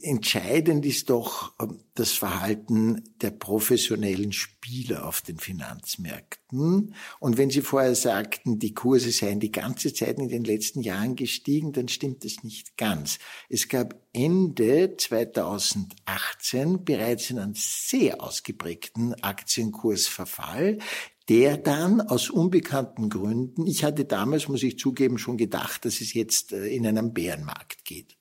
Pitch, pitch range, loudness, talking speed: 120 Hz, 110-140 Hz, -26 LUFS, 130 wpm